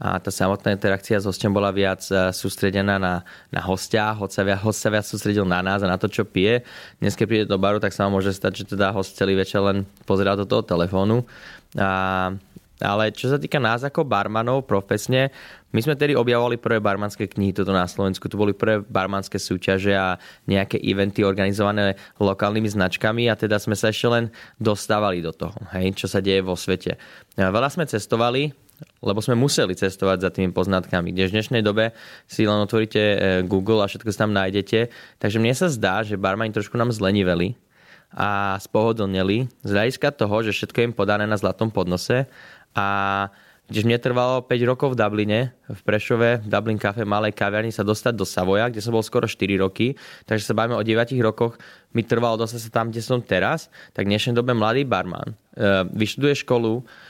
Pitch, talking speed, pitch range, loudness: 105 Hz, 190 wpm, 95-115 Hz, -22 LUFS